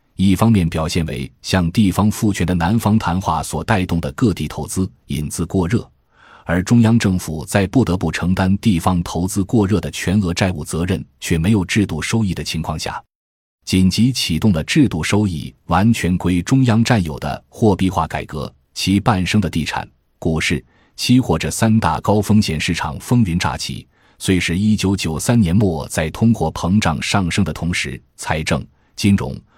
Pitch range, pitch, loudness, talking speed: 80-105 Hz, 90 Hz, -18 LUFS, 260 characters per minute